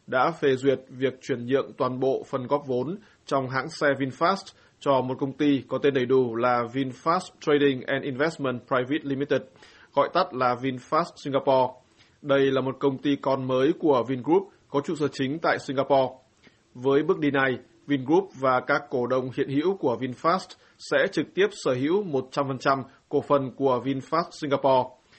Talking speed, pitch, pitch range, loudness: 175 wpm, 135 Hz, 130-145 Hz, -25 LUFS